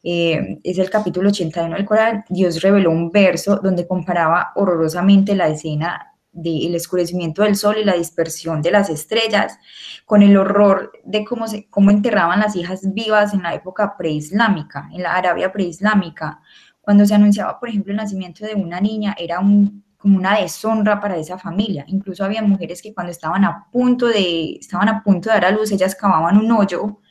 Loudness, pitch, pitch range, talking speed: -17 LUFS, 195 Hz, 175-210 Hz, 185 wpm